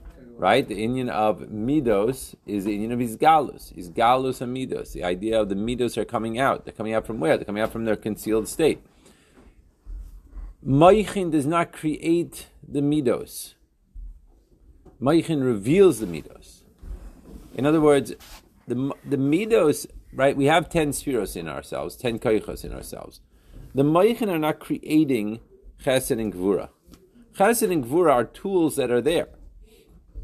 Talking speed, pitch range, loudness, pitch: 150 wpm, 105-150 Hz, -23 LUFS, 125 Hz